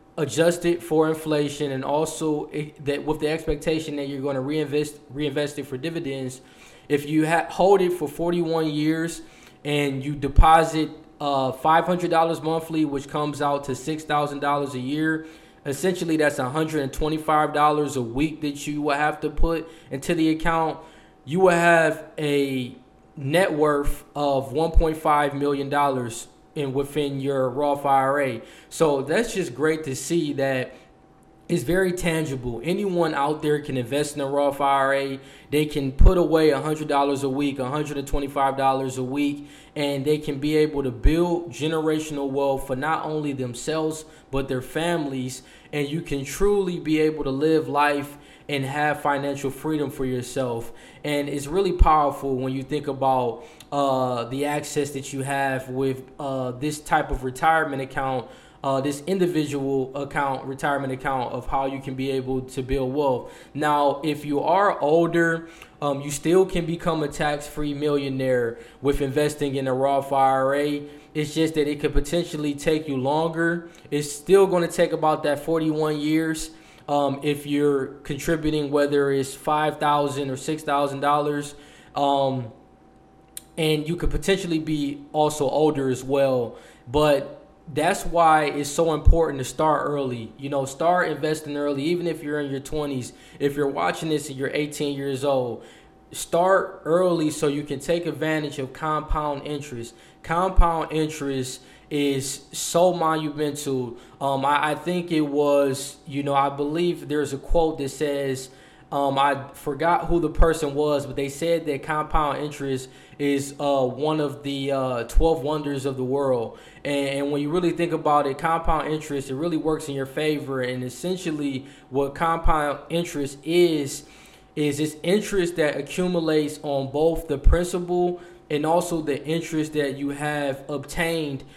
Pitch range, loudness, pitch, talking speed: 140-155 Hz, -24 LUFS, 145 Hz, 160 wpm